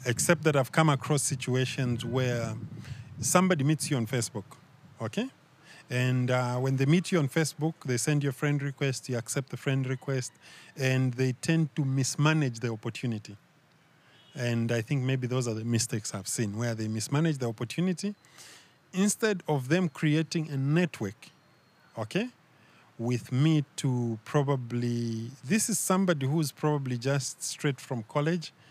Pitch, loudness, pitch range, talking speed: 135 Hz, -29 LUFS, 120-155 Hz, 155 wpm